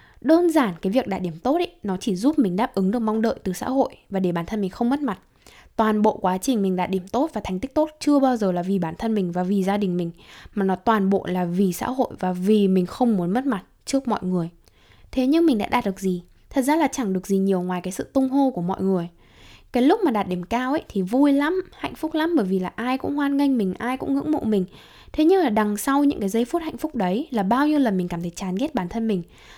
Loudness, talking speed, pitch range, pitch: -23 LUFS, 290 wpm, 185-275 Hz, 215 Hz